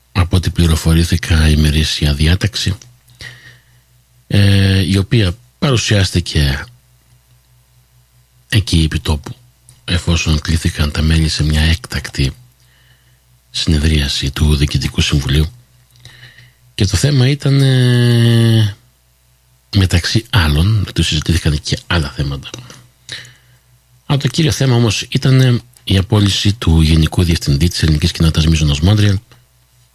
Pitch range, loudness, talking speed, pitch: 80-125 Hz, -14 LUFS, 95 wpm, 100 Hz